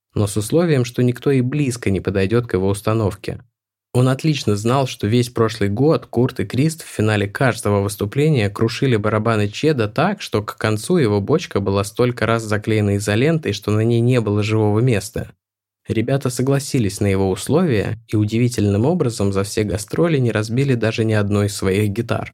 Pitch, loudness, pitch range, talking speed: 110 Hz, -19 LUFS, 105-130 Hz, 175 wpm